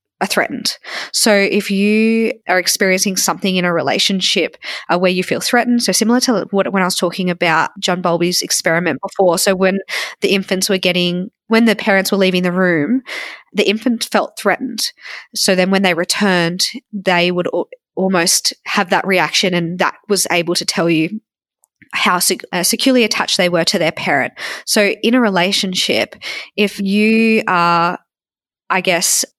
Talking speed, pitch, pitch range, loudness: 170 wpm, 190 Hz, 180-215 Hz, -15 LUFS